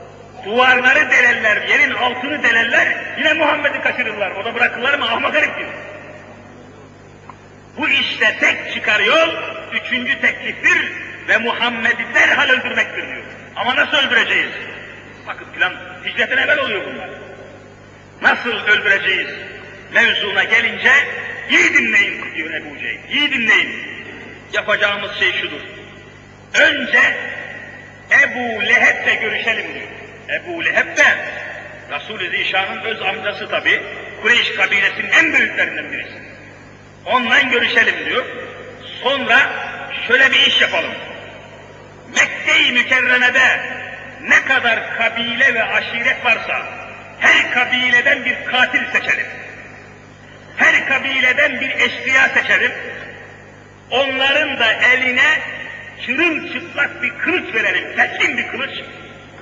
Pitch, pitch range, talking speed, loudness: 255 Hz, 235-310 Hz, 105 wpm, -14 LUFS